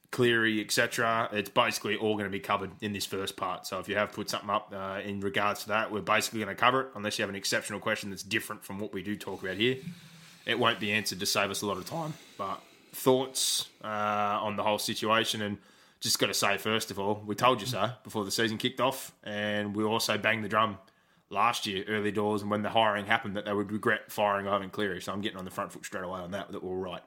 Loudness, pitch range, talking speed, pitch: -30 LUFS, 100-115 Hz, 260 wpm, 105 Hz